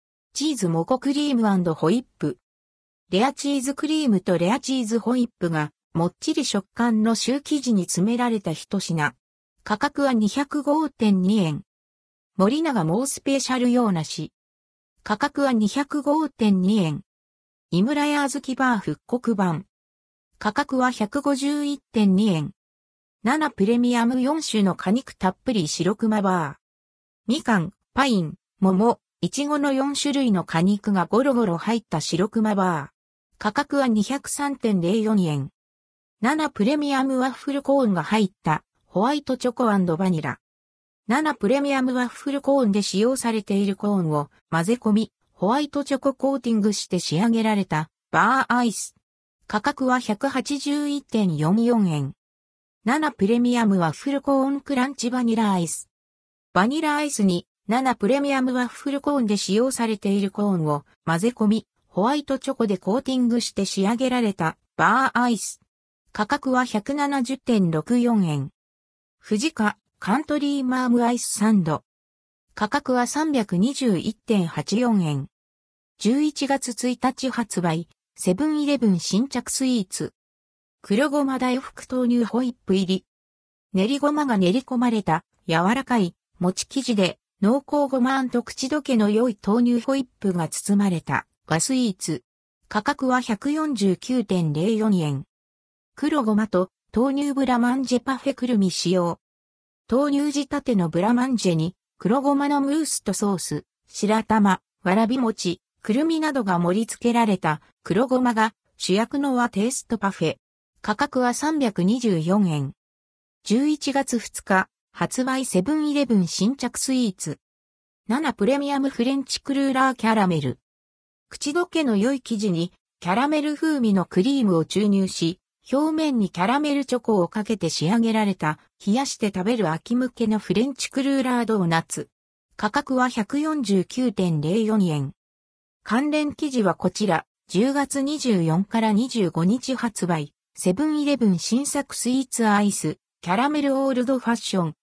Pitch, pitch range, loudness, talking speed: 220 Hz, 180-265 Hz, -23 LUFS, 270 characters per minute